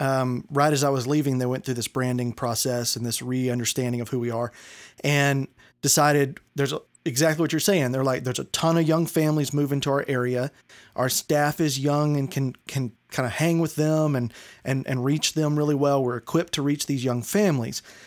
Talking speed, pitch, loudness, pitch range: 215 wpm, 140 Hz, -24 LUFS, 125-150 Hz